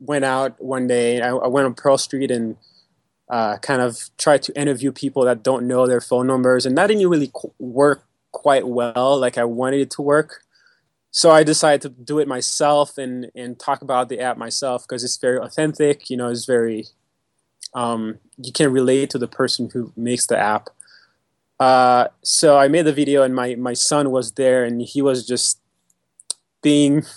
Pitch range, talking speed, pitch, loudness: 125-140 Hz, 195 wpm, 130 Hz, -18 LUFS